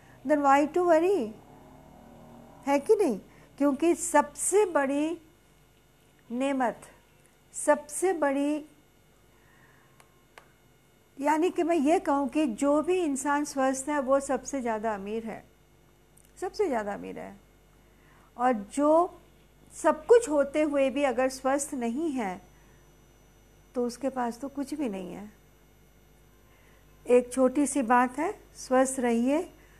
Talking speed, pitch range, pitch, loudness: 115 wpm, 260-310 Hz, 285 Hz, -27 LUFS